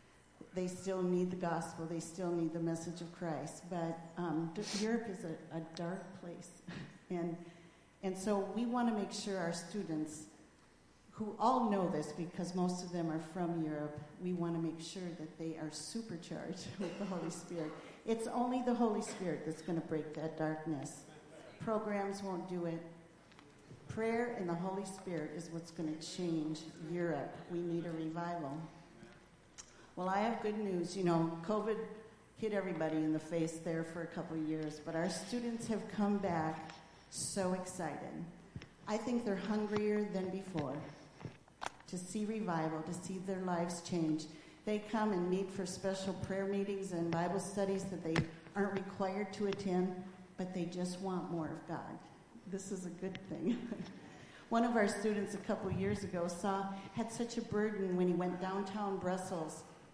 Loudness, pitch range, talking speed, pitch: -39 LUFS, 165-195 Hz, 175 wpm, 180 Hz